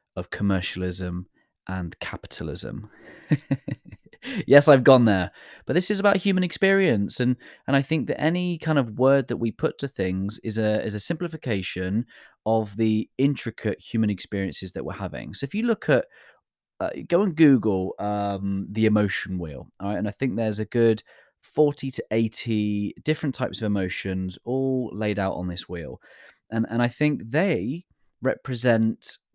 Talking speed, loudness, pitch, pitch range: 165 wpm, -24 LUFS, 110 Hz, 100-140 Hz